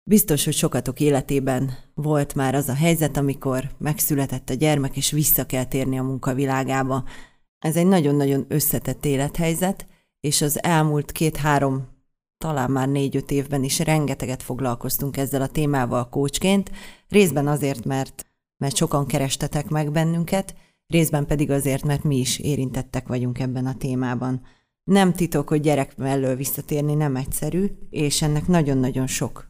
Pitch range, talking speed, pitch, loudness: 130-155 Hz, 140 wpm, 140 Hz, -22 LUFS